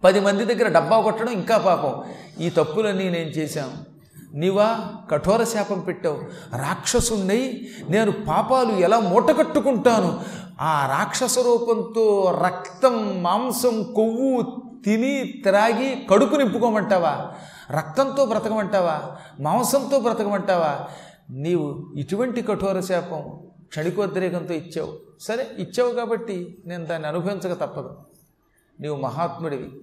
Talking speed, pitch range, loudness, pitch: 100 wpm, 175-235 Hz, -22 LUFS, 205 Hz